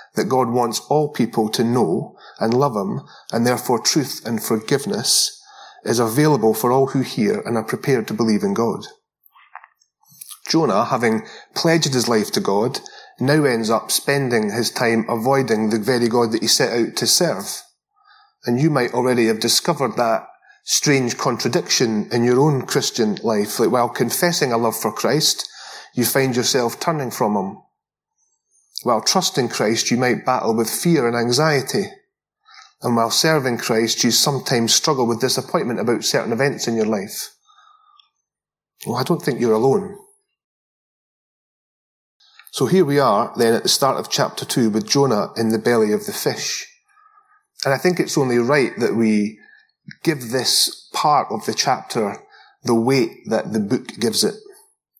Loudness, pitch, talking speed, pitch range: -19 LUFS, 130 Hz, 165 wpm, 115-185 Hz